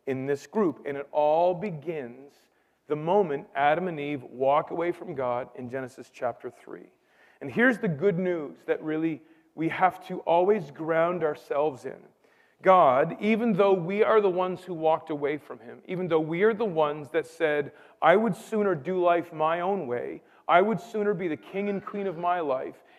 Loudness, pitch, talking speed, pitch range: -26 LUFS, 170 Hz, 190 wpm, 150-195 Hz